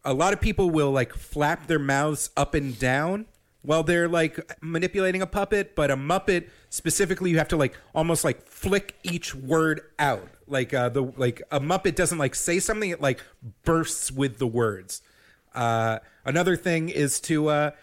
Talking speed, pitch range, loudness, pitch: 180 wpm, 135-175 Hz, -25 LUFS, 155 Hz